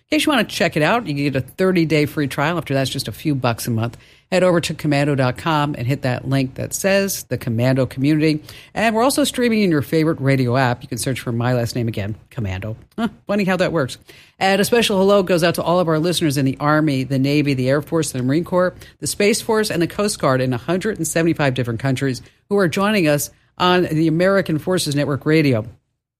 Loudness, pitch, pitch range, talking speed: -19 LUFS, 150 Hz, 130-180 Hz, 235 wpm